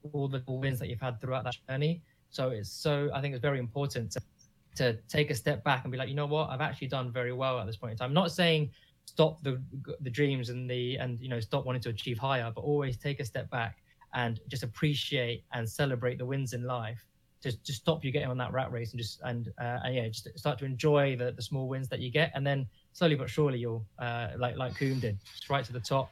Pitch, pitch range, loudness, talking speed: 130 Hz, 120-140 Hz, -33 LUFS, 260 wpm